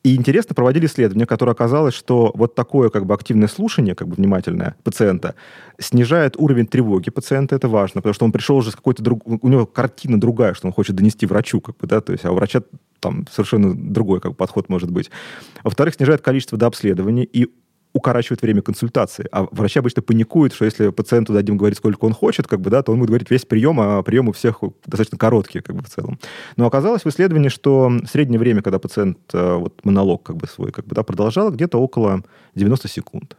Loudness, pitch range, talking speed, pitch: -17 LUFS, 105-130 Hz, 210 wpm, 120 Hz